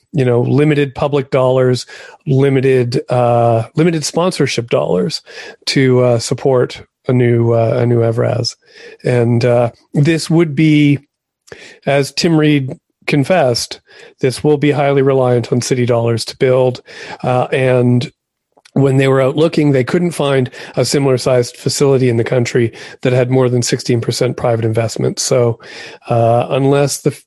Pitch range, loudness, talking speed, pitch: 120-145 Hz, -14 LUFS, 145 wpm, 130 Hz